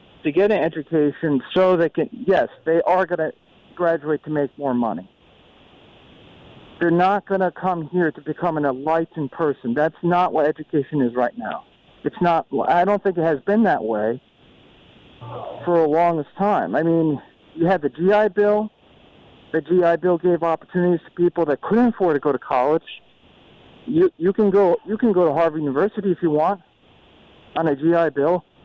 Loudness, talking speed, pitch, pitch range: -20 LUFS, 180 wpm, 170 Hz, 150-185 Hz